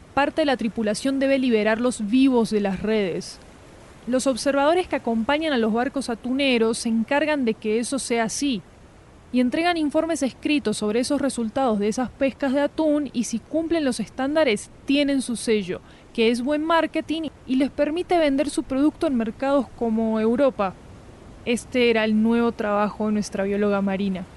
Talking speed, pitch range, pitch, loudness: 170 wpm, 220-285 Hz, 250 Hz, -23 LUFS